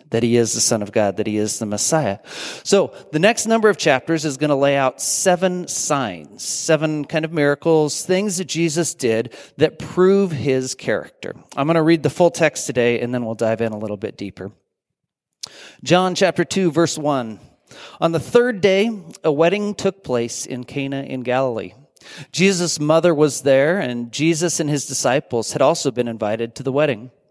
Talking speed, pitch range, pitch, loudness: 190 wpm, 120-170 Hz, 145 Hz, -19 LUFS